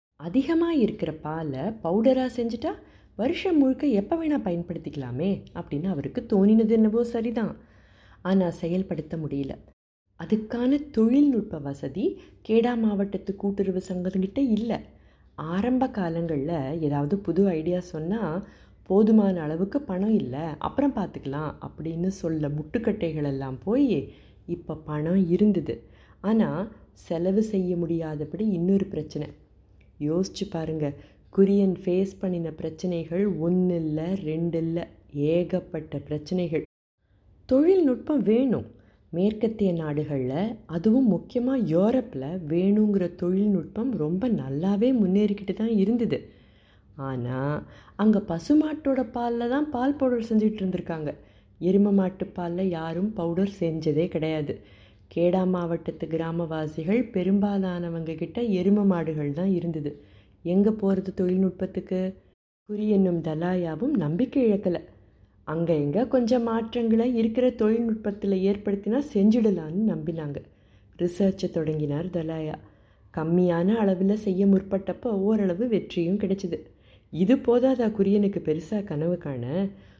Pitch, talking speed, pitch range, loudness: 185 Hz, 100 wpm, 160-215 Hz, -26 LUFS